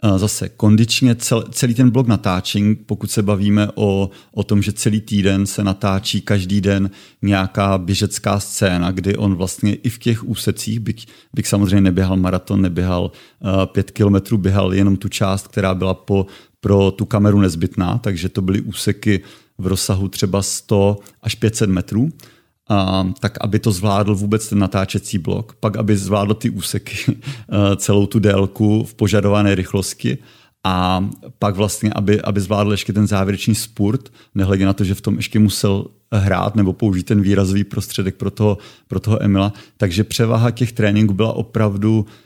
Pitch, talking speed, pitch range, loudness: 105 Hz, 160 wpm, 100-110 Hz, -17 LUFS